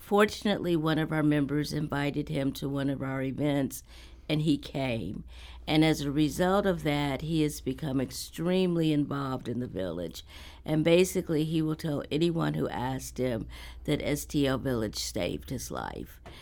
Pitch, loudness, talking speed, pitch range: 145 Hz, -29 LUFS, 160 wpm, 125-155 Hz